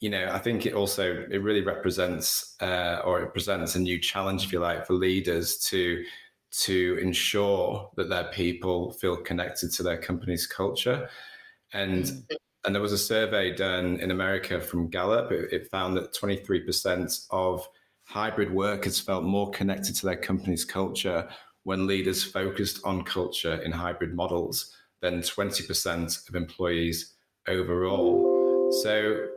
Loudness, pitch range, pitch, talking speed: -28 LUFS, 90-100 Hz, 95 Hz, 155 wpm